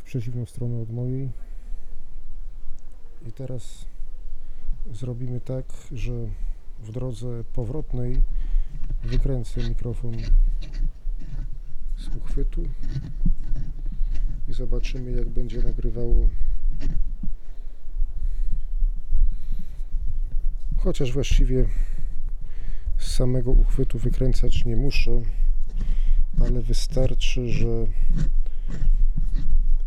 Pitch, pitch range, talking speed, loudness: 120 Hz, 110-130 Hz, 65 wpm, -29 LUFS